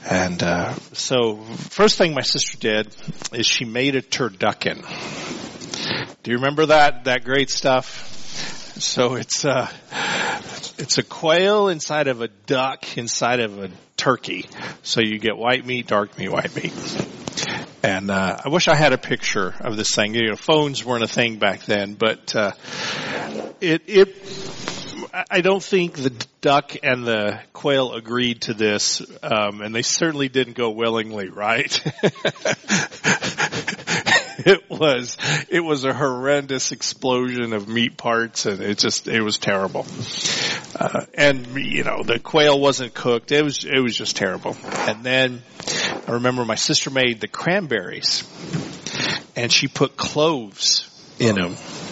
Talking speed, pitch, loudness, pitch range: 150 wpm, 125 Hz, -20 LUFS, 115-145 Hz